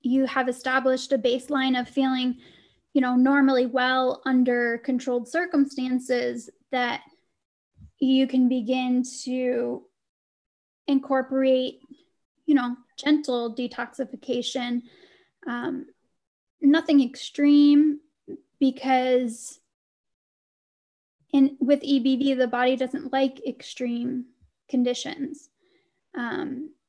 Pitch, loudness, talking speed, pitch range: 265 Hz, -24 LUFS, 85 wpm, 250-285 Hz